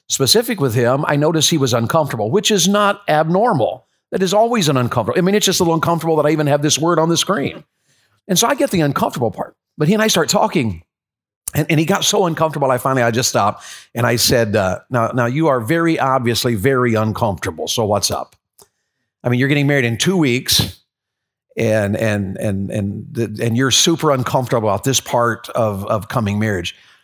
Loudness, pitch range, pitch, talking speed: -16 LUFS, 115-165 Hz, 135 Hz, 215 wpm